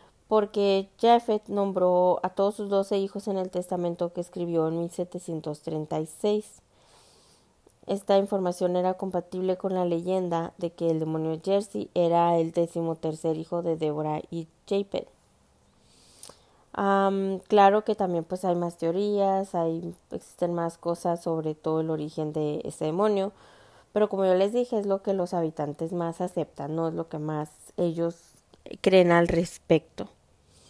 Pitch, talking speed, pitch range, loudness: 175 Hz, 150 wpm, 165-195 Hz, -27 LUFS